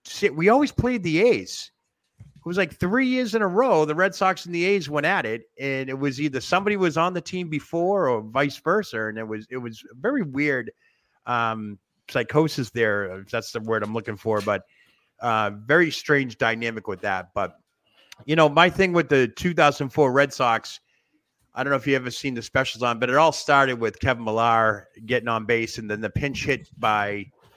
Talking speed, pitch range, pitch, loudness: 205 wpm, 115-170 Hz, 140 Hz, -23 LUFS